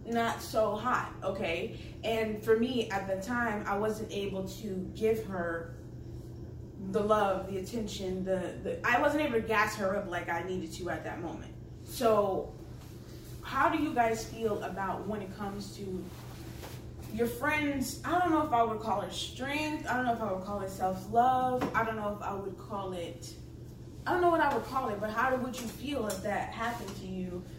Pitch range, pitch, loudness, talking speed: 185-235 Hz, 215 Hz, -32 LUFS, 205 wpm